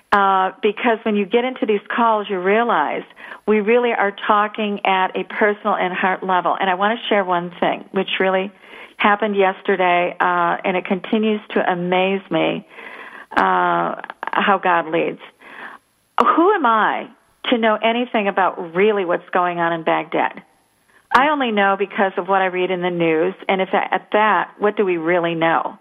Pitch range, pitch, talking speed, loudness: 180-215 Hz, 195 Hz, 175 wpm, -18 LUFS